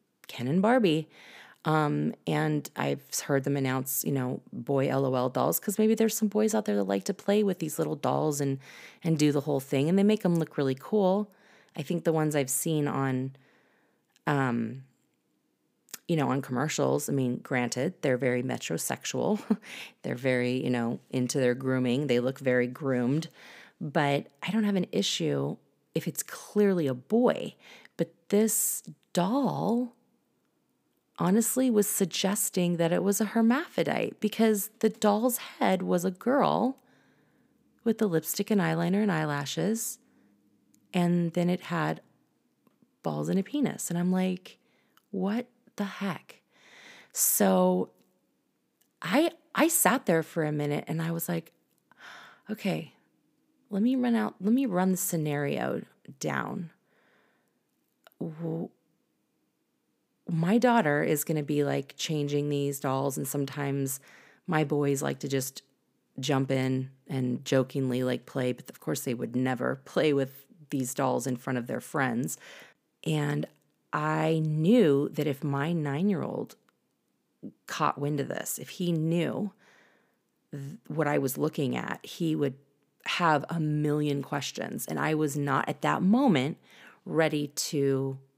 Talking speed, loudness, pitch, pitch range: 150 wpm, -28 LUFS, 155 Hz, 135-200 Hz